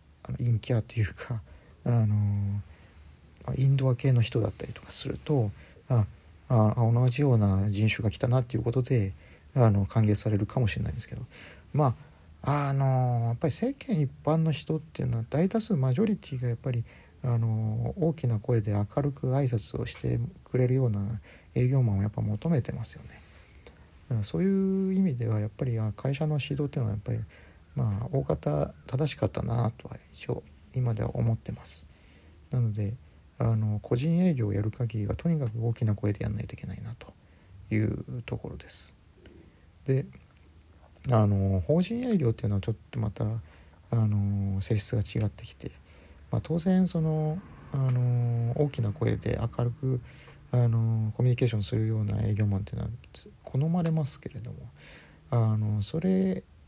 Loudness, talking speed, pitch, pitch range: -29 LUFS, 330 characters per minute, 115 Hz, 100-130 Hz